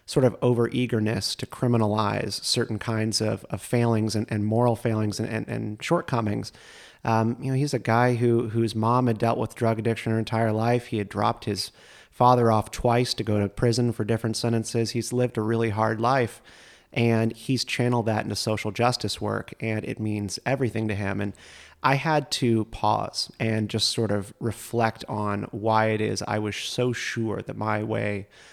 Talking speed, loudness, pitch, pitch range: 190 wpm, -25 LUFS, 115 Hz, 110-120 Hz